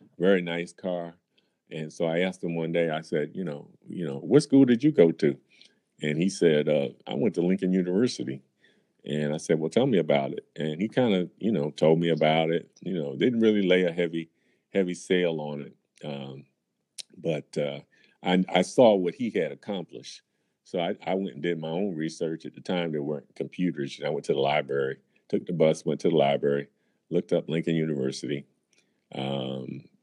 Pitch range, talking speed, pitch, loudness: 75-90 Hz, 205 wpm, 80 Hz, -27 LUFS